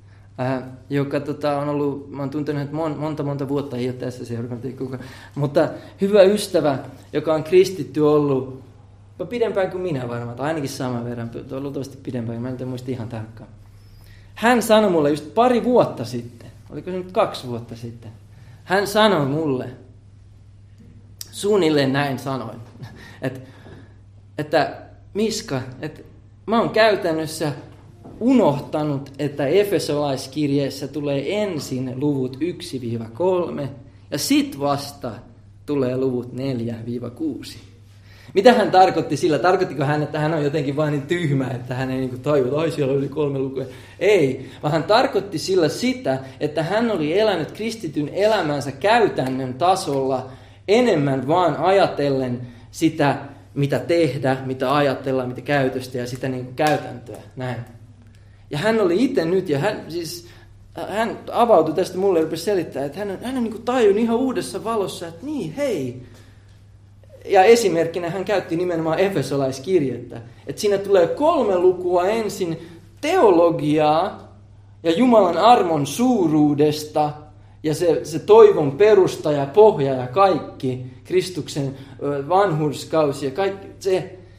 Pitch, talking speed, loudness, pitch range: 140 Hz, 135 wpm, -20 LUFS, 125-175 Hz